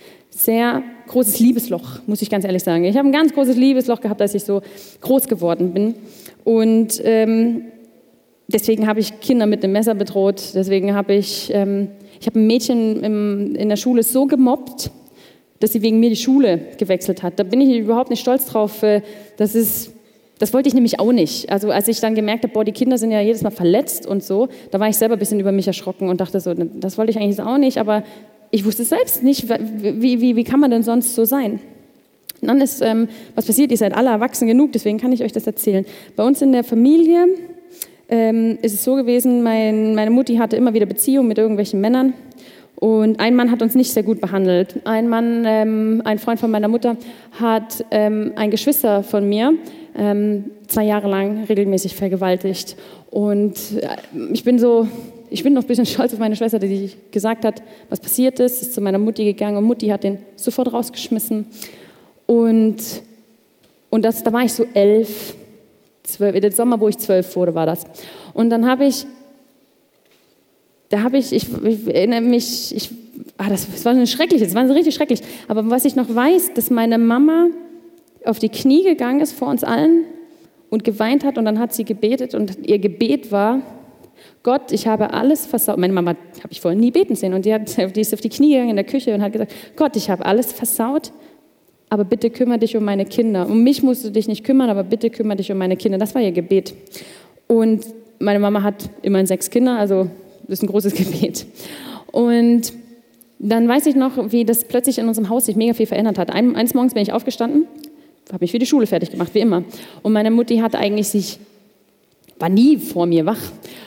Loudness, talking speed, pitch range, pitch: -17 LUFS, 205 wpm, 205-245 Hz, 225 Hz